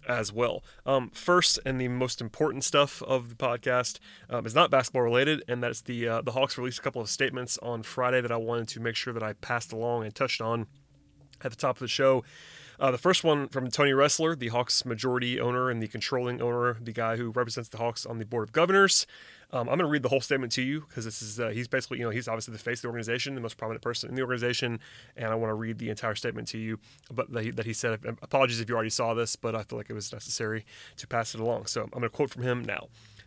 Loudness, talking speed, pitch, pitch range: -29 LUFS, 265 wpm, 120 Hz, 115-130 Hz